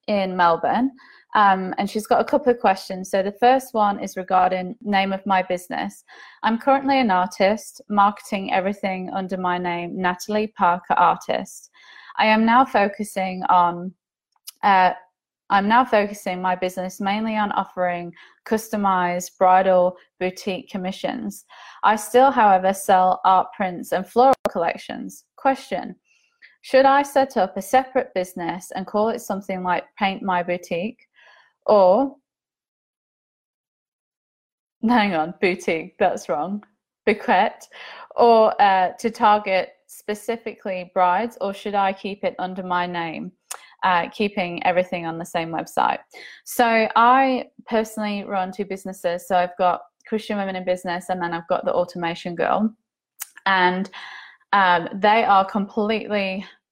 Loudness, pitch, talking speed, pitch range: -21 LUFS, 195 Hz, 135 wpm, 185-220 Hz